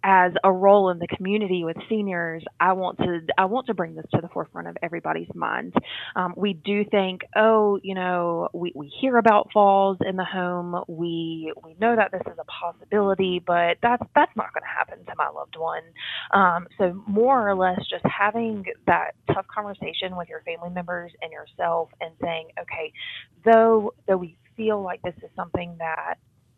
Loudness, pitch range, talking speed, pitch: -24 LUFS, 175-205 Hz, 190 wpm, 185 Hz